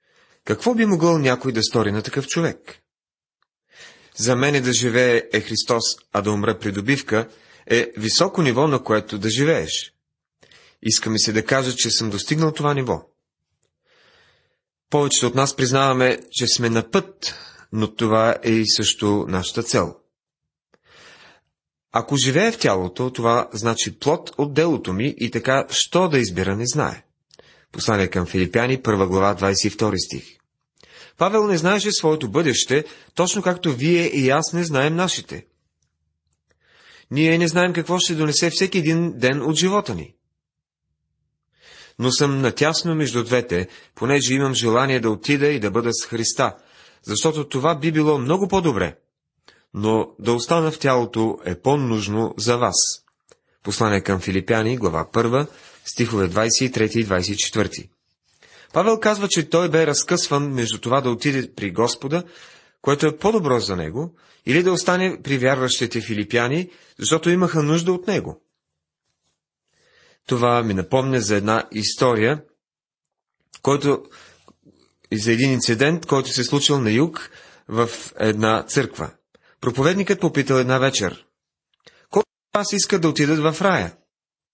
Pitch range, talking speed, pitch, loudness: 110-155 Hz, 140 wpm, 130 Hz, -20 LUFS